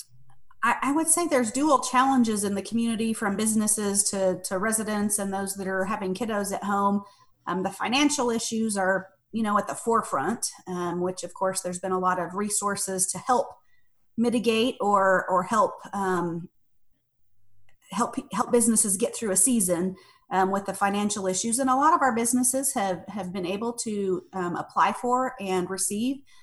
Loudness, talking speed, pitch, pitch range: -25 LUFS, 175 wpm, 200 Hz, 185-235 Hz